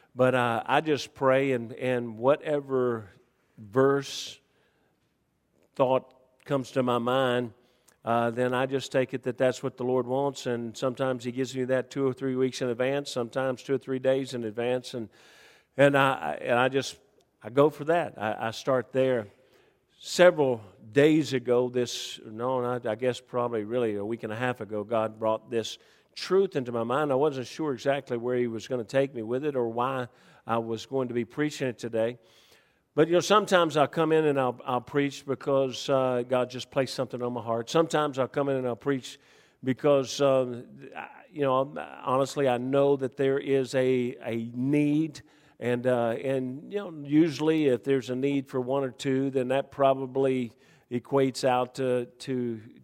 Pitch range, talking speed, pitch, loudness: 120-140 Hz, 185 wpm, 130 Hz, -27 LUFS